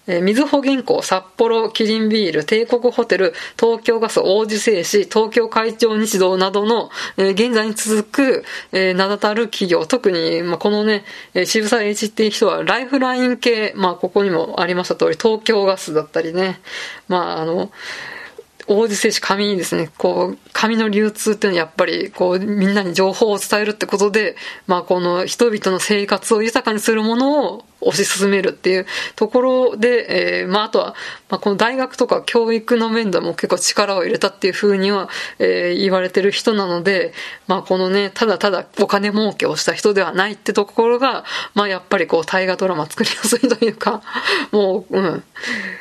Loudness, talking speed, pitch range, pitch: -17 LUFS, 360 characters per minute, 190-230 Hz, 210 Hz